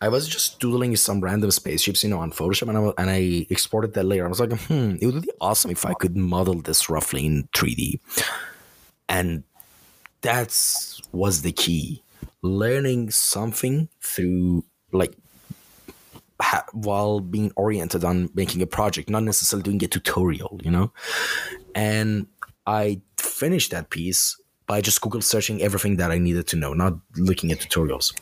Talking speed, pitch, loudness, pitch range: 165 wpm, 95 Hz, -22 LUFS, 90-105 Hz